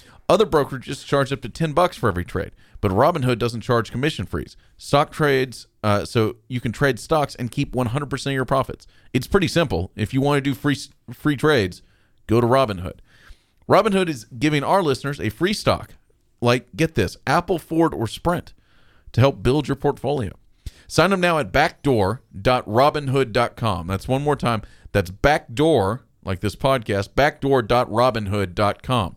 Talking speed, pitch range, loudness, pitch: 165 wpm, 110-145 Hz, -21 LUFS, 130 Hz